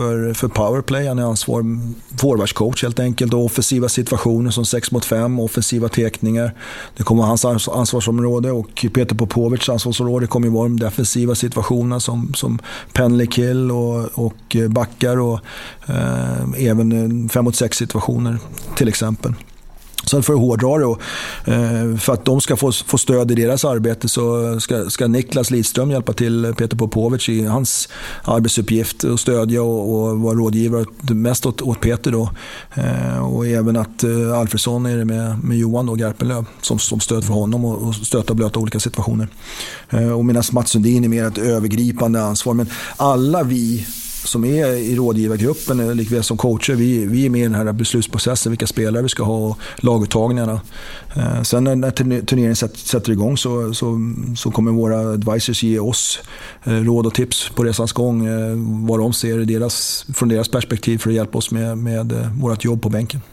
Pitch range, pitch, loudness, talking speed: 115-120 Hz, 115 Hz, -18 LUFS, 155 wpm